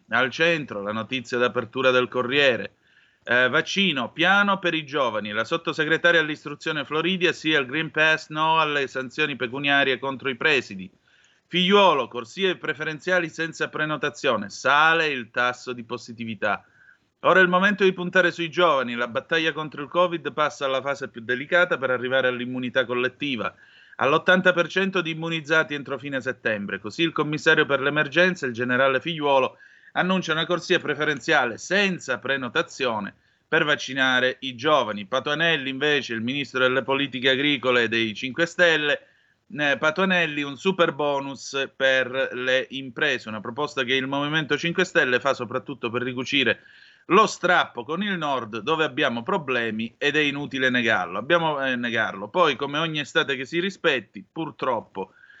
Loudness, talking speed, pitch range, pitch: -23 LUFS, 145 wpm, 130-165 Hz, 145 Hz